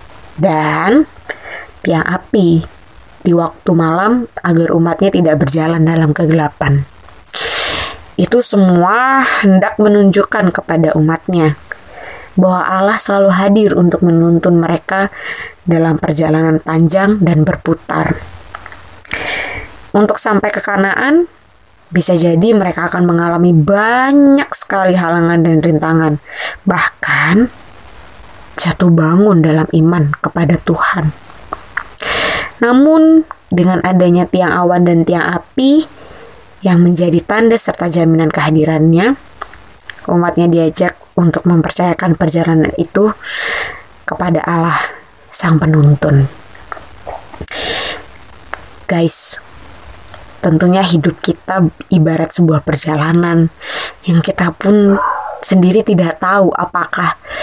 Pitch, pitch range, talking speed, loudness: 170 Hz, 160-195 Hz, 90 wpm, -12 LUFS